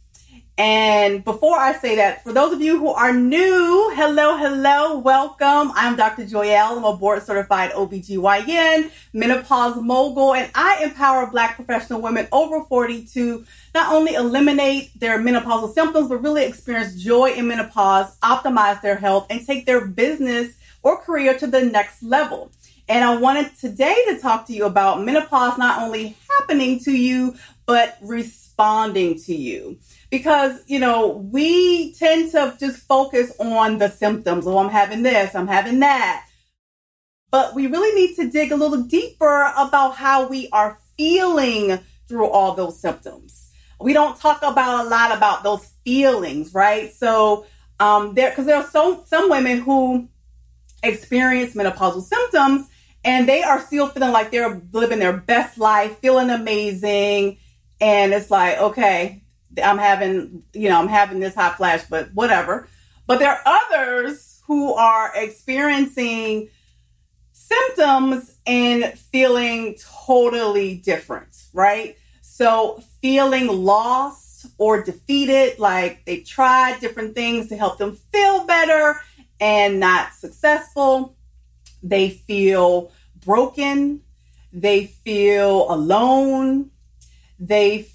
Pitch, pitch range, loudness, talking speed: 240 Hz, 205-275 Hz, -18 LUFS, 140 wpm